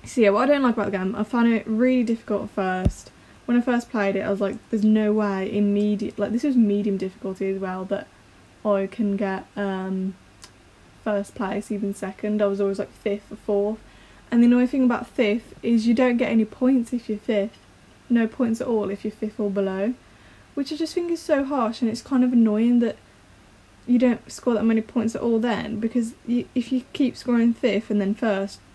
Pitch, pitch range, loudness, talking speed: 220 Hz, 200-240 Hz, -23 LUFS, 225 wpm